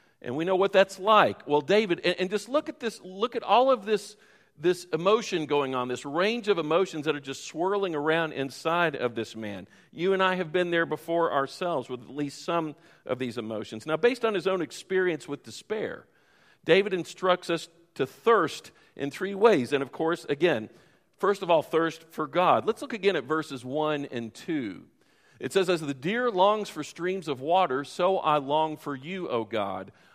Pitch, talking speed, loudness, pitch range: 170 Hz, 200 wpm, -27 LUFS, 145-190 Hz